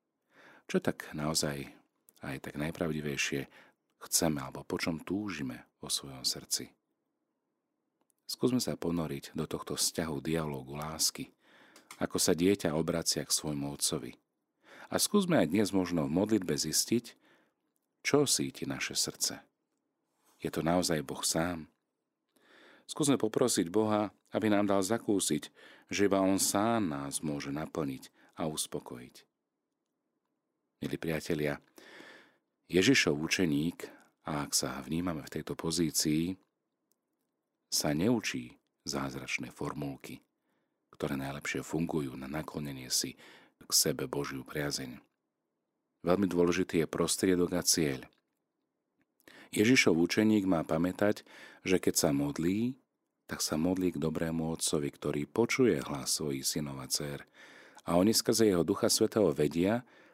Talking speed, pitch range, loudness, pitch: 120 wpm, 75-95 Hz, -31 LUFS, 80 Hz